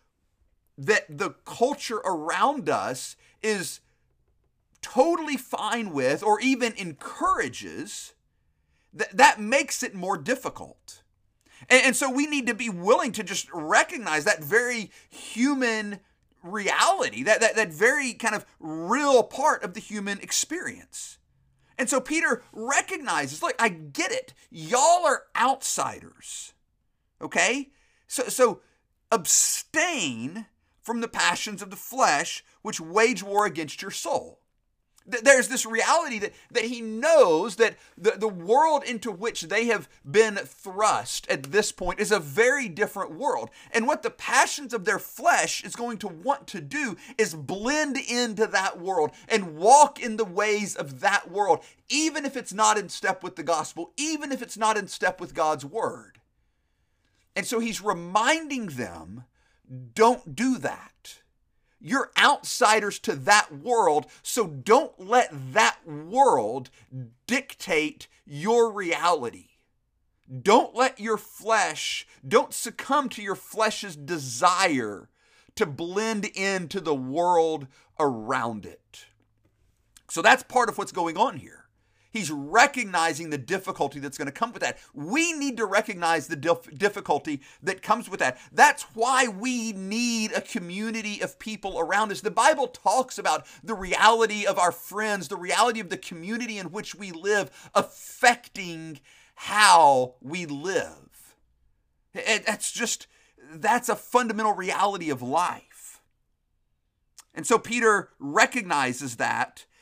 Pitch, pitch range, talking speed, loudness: 215 Hz, 175-245 Hz, 140 wpm, -24 LUFS